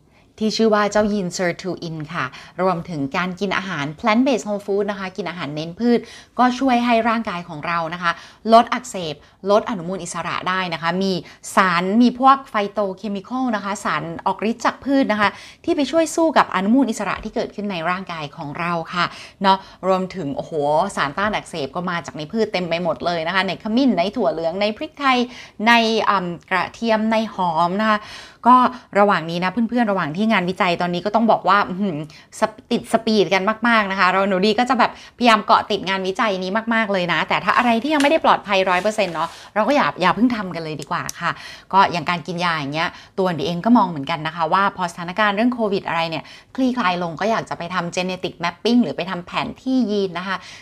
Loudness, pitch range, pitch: -20 LUFS, 175-225 Hz, 195 Hz